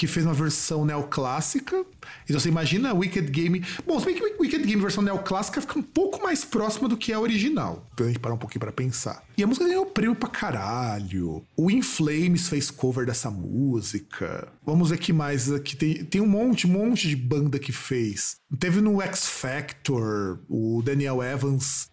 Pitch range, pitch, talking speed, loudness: 130-215 Hz, 160 Hz, 205 wpm, -25 LUFS